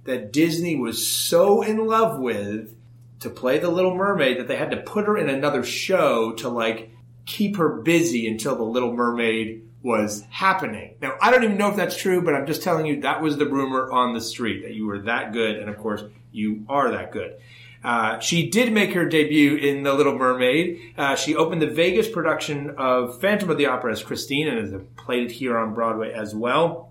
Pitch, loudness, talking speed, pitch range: 130 Hz, -22 LUFS, 215 wpm, 115-165 Hz